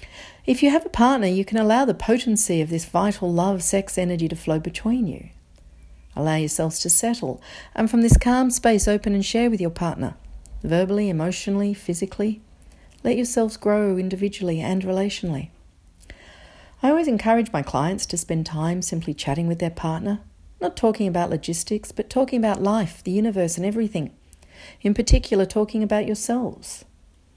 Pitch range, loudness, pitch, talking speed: 160-215 Hz, -22 LUFS, 185 Hz, 160 wpm